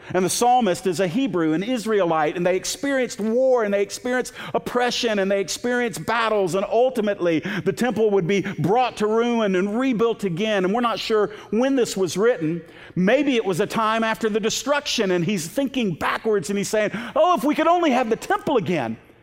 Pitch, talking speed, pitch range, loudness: 220 Hz, 200 wpm, 190-245 Hz, -21 LUFS